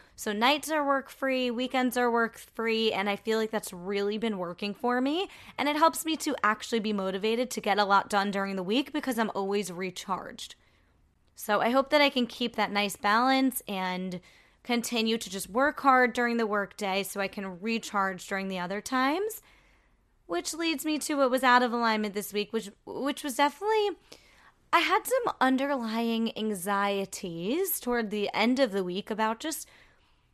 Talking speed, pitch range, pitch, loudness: 185 wpm, 200-270 Hz, 225 Hz, -28 LUFS